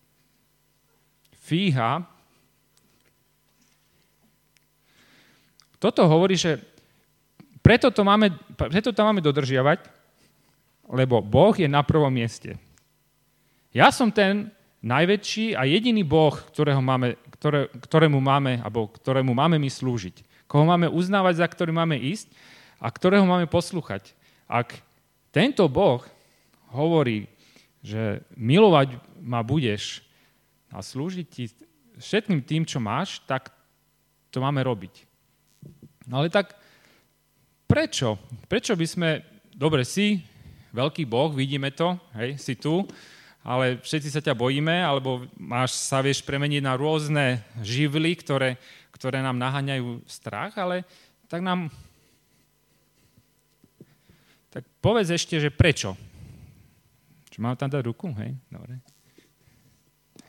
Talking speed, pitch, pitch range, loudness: 110 wpm, 145 Hz, 130-175 Hz, -23 LUFS